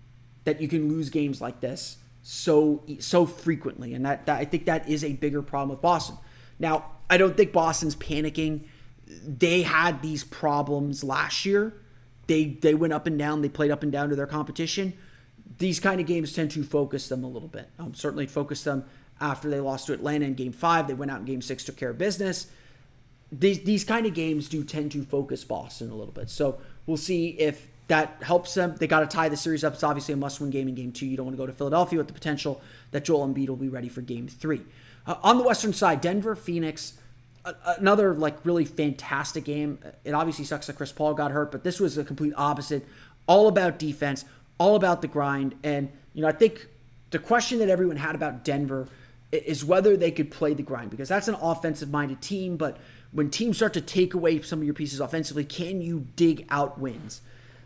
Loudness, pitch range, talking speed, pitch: -26 LUFS, 135-165 Hz, 220 wpm, 150 Hz